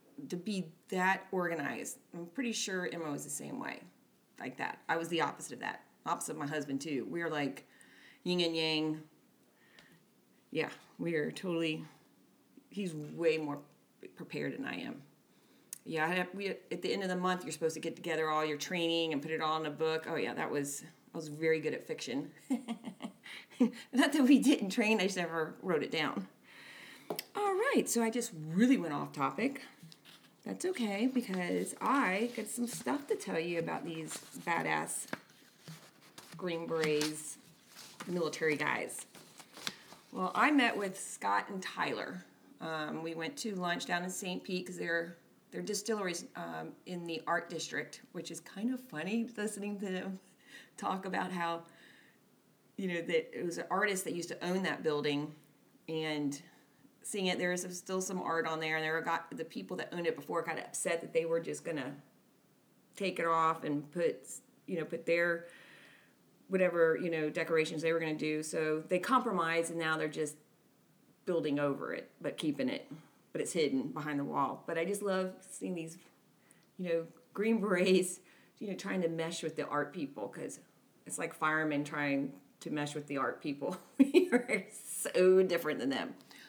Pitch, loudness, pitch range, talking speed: 170 Hz, -35 LUFS, 160-195 Hz, 180 wpm